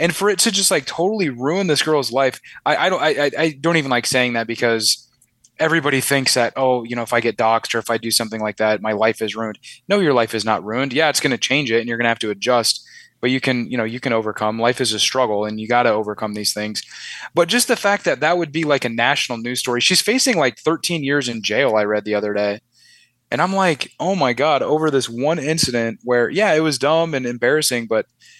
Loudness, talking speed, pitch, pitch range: -18 LUFS, 260 wpm, 120 Hz, 115-155 Hz